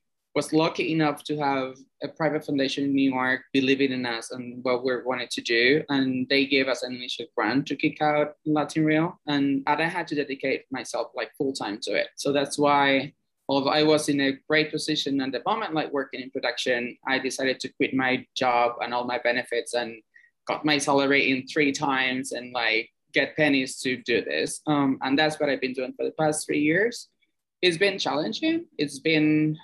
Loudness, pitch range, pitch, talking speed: -25 LUFS, 130-150 Hz, 140 Hz, 205 wpm